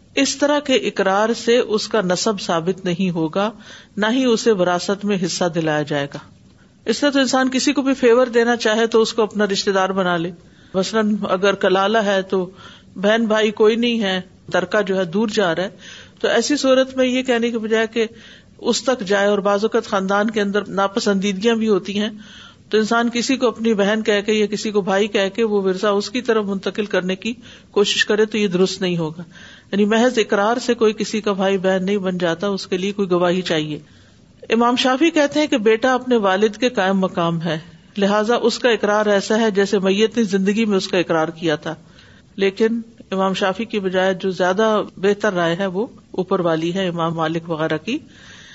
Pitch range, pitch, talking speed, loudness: 190-225 Hz, 205 Hz, 210 wpm, -18 LUFS